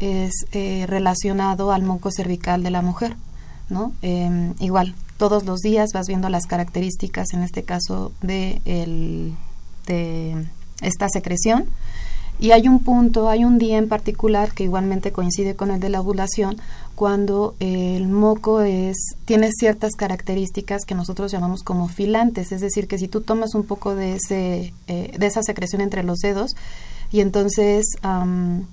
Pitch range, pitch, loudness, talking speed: 180-210 Hz, 195 Hz, -21 LUFS, 160 wpm